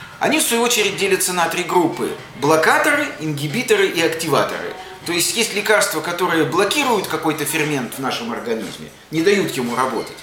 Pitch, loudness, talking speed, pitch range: 180 Hz, -18 LUFS, 160 wpm, 155-210 Hz